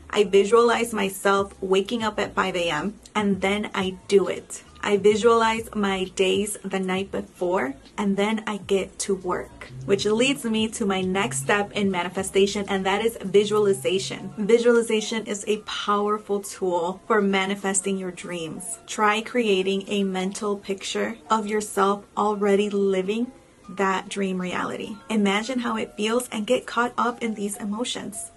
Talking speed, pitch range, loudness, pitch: 150 wpm, 195-220 Hz, -24 LUFS, 205 Hz